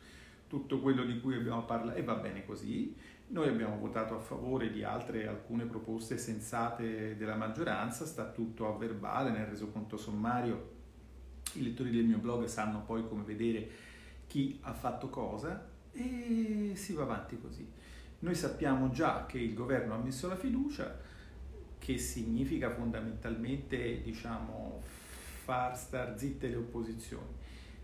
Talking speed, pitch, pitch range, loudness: 140 wpm, 115 Hz, 110-125 Hz, -38 LUFS